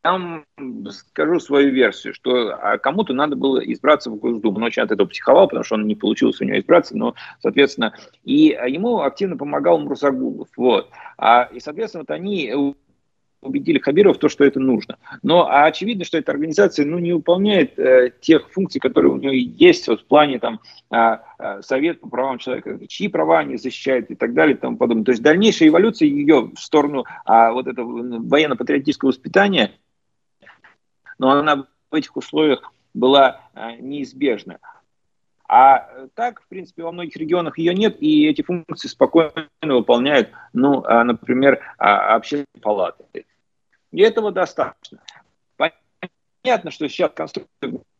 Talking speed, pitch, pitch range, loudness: 150 wpm, 150 Hz, 130-175 Hz, -17 LUFS